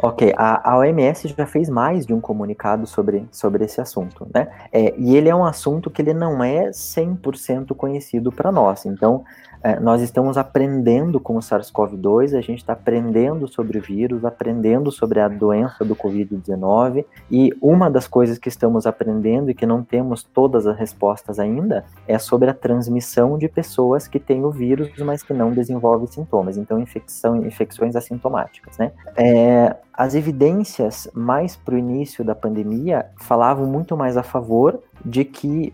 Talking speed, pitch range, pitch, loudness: 170 wpm, 115-135 Hz, 120 Hz, -19 LUFS